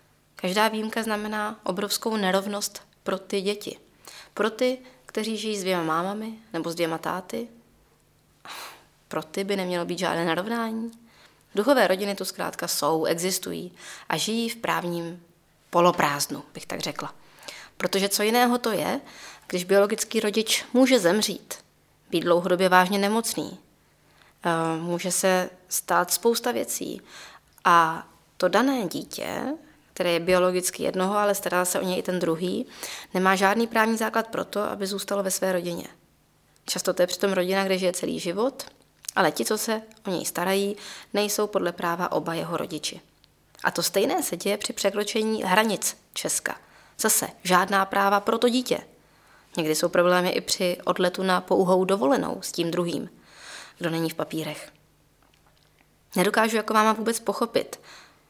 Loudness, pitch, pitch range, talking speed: -25 LUFS, 195 Hz, 180-220 Hz, 150 wpm